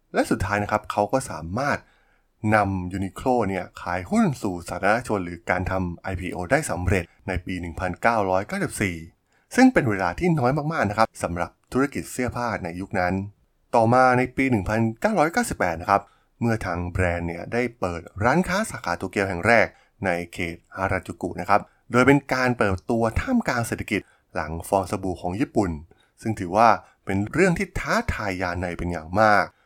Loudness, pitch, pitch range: -24 LUFS, 100 Hz, 90-120 Hz